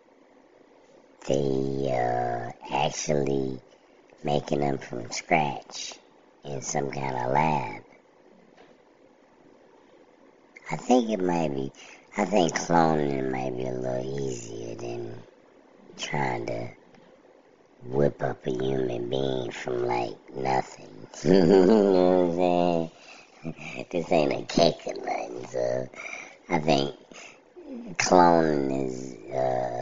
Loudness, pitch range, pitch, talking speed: -26 LUFS, 65-80 Hz, 70 Hz, 105 wpm